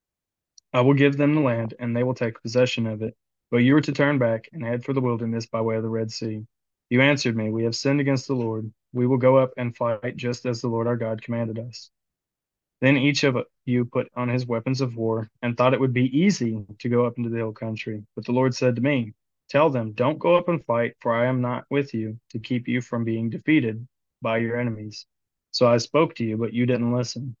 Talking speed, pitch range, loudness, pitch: 245 wpm, 115-130 Hz, -24 LUFS, 120 Hz